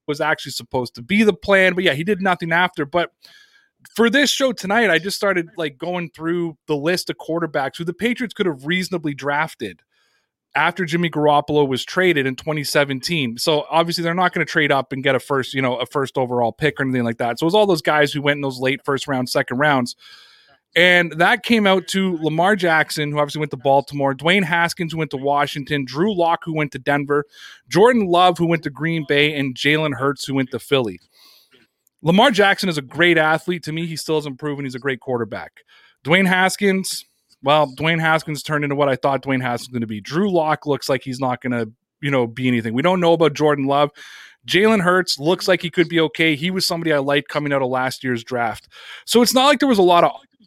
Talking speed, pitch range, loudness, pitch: 230 wpm, 140-175 Hz, -18 LUFS, 155 Hz